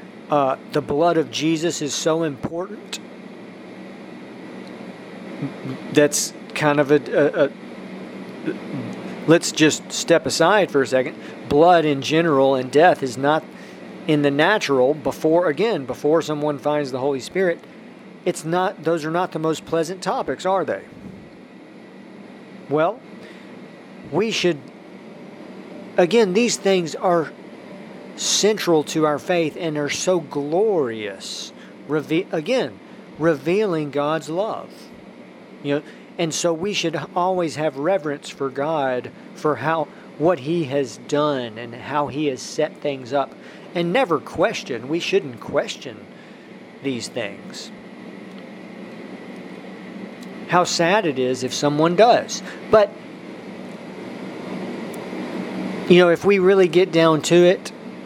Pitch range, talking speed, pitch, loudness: 145-180 Hz, 125 wpm, 160 Hz, -20 LUFS